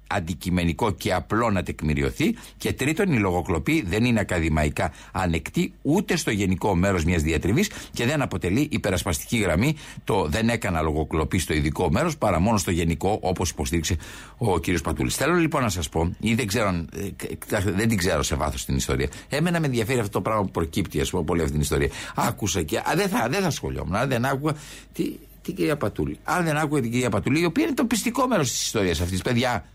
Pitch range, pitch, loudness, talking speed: 85-125 Hz, 100 Hz, -24 LUFS, 190 wpm